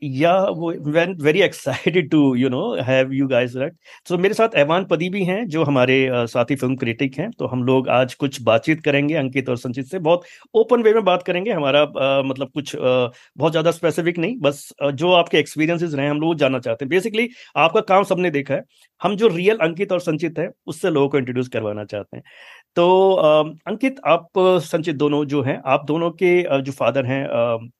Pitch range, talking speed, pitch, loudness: 135-180 Hz, 210 wpm, 155 Hz, -19 LUFS